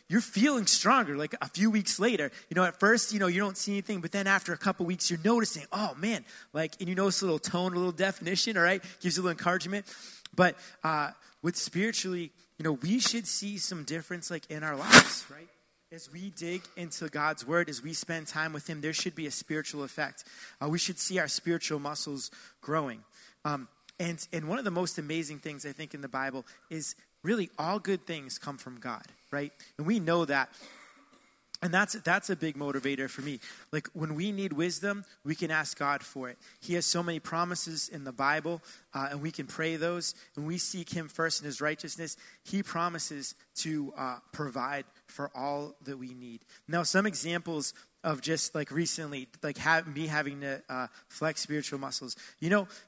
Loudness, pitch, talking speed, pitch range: -30 LUFS, 165 Hz, 210 wpm, 150-190 Hz